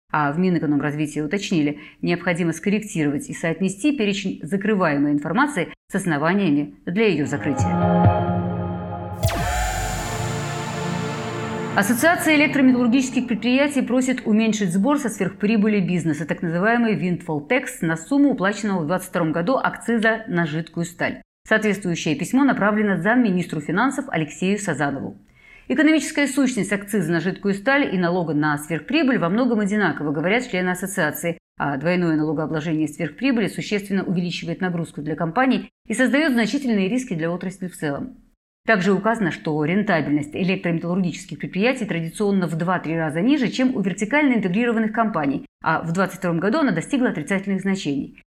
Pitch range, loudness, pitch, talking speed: 160-225 Hz, -21 LUFS, 185 Hz, 130 wpm